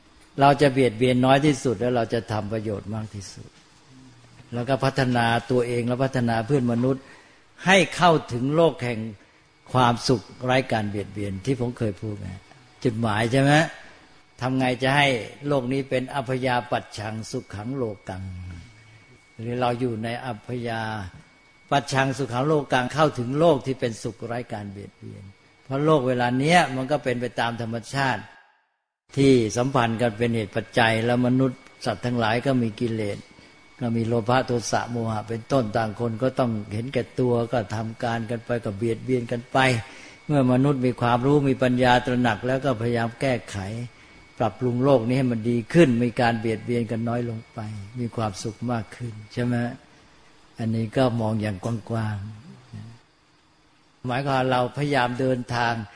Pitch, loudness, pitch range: 120 Hz, -24 LUFS, 115-130 Hz